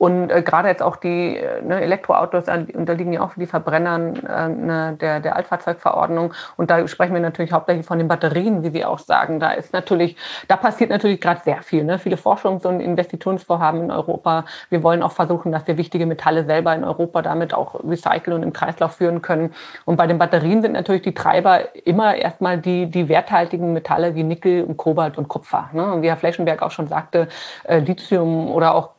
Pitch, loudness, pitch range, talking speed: 170 Hz, -19 LUFS, 165-180 Hz, 205 wpm